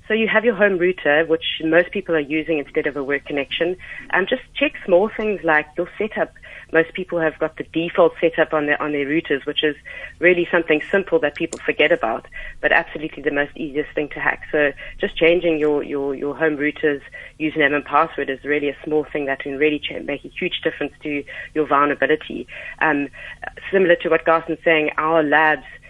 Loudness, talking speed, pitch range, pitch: -20 LUFS, 210 wpm, 145-170 Hz, 155 Hz